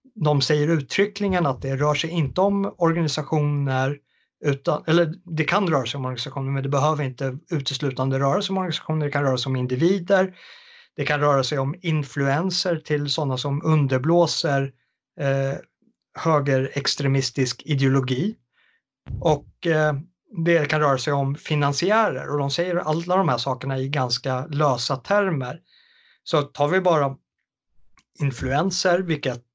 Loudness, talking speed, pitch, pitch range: -23 LUFS, 145 wpm, 150 Hz, 135-175 Hz